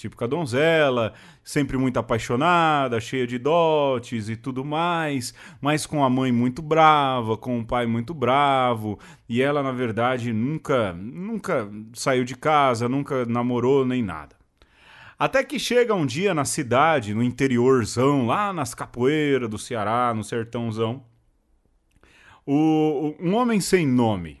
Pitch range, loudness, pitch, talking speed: 120-150 Hz, -22 LUFS, 130 Hz, 145 wpm